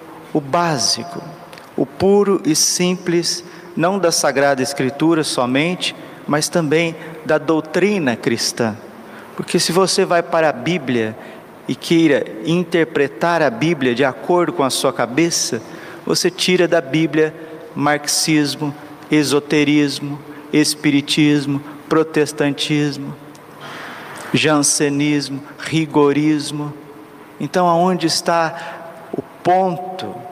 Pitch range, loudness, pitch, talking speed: 145-170 Hz, -17 LUFS, 155 Hz, 95 wpm